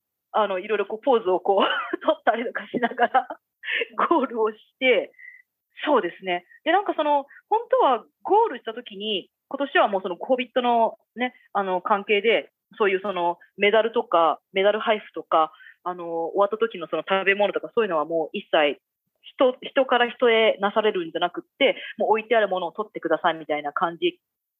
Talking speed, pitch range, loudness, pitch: 355 characters per minute, 185-285 Hz, -23 LUFS, 220 Hz